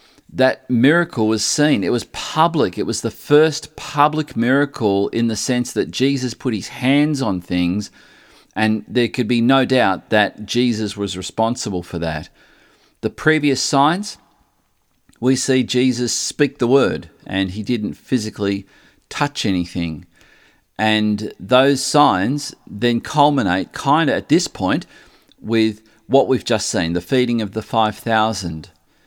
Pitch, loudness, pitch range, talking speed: 120 Hz, -18 LUFS, 105-135 Hz, 145 wpm